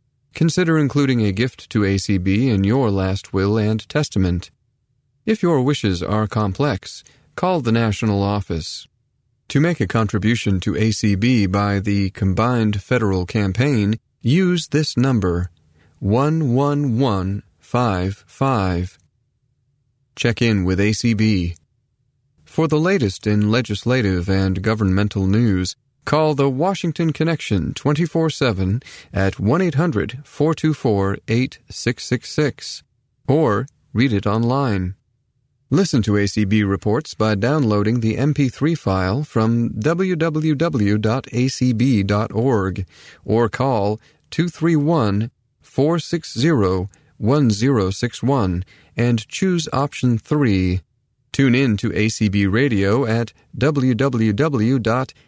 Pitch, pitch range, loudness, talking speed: 115 Hz, 100-140 Hz, -19 LUFS, 100 wpm